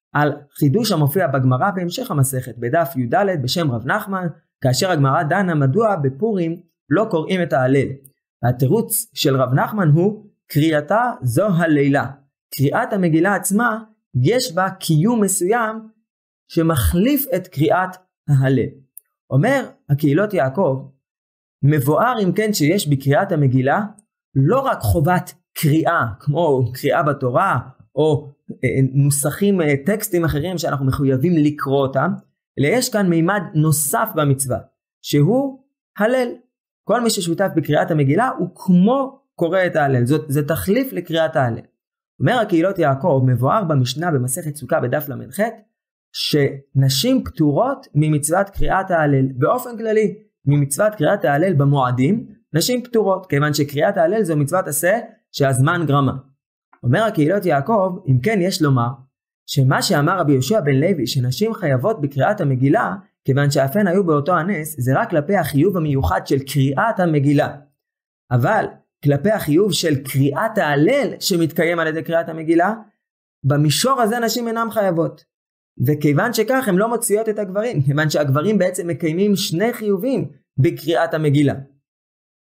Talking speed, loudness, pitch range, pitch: 130 wpm, -18 LUFS, 140-200 Hz, 160 Hz